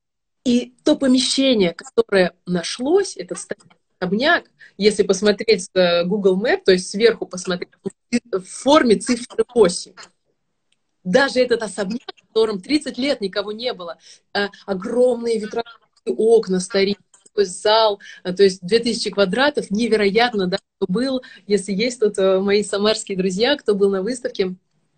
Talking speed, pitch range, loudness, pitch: 125 wpm, 195-240 Hz, -19 LUFS, 210 Hz